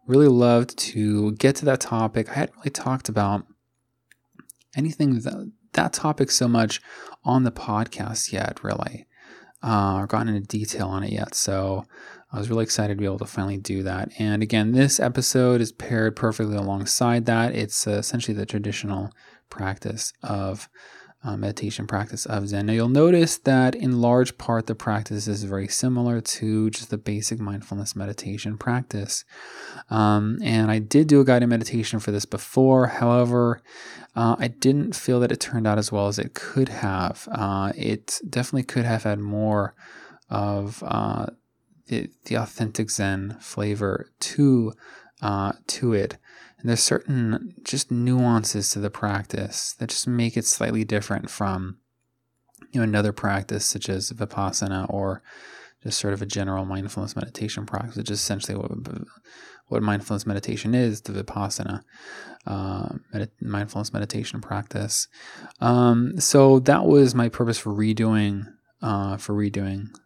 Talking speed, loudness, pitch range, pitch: 155 wpm, -23 LUFS, 100-120 Hz, 110 Hz